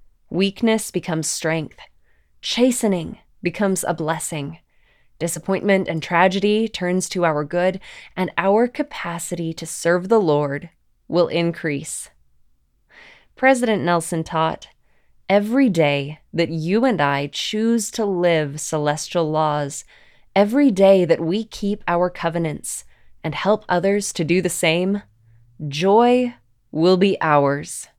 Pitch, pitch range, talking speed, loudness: 175 Hz, 155-200 Hz, 120 wpm, -20 LUFS